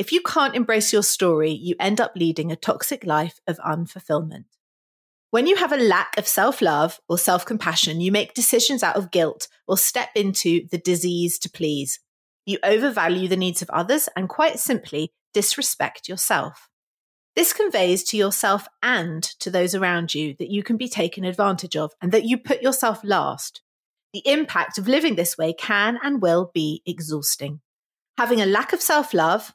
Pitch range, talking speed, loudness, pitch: 170-235 Hz, 180 wpm, -21 LUFS, 195 Hz